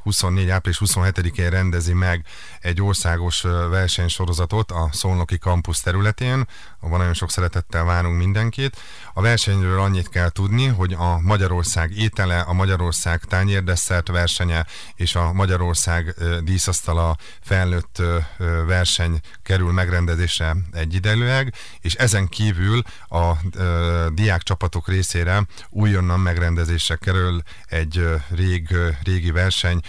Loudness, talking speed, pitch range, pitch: -20 LUFS, 110 wpm, 85-95 Hz, 90 Hz